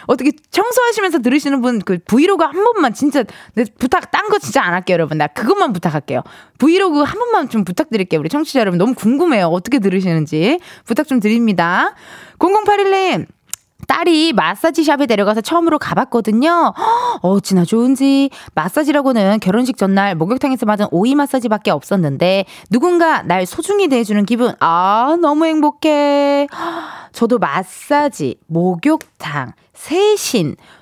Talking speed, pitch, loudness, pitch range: 340 characters per minute, 265 Hz, -15 LUFS, 200-325 Hz